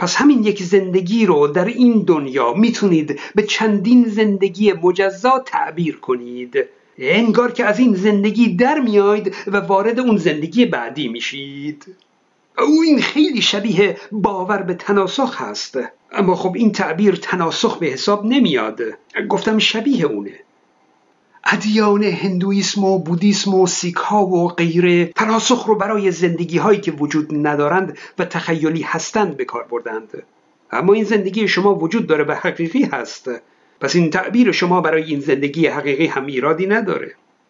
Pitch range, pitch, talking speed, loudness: 175-220 Hz, 200 Hz, 140 wpm, -16 LUFS